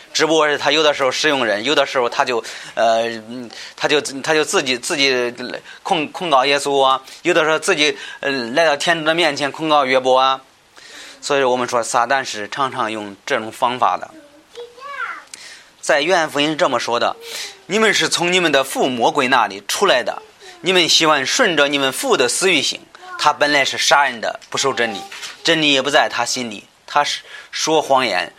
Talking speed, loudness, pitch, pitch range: 270 characters per minute, -16 LUFS, 145 Hz, 130-170 Hz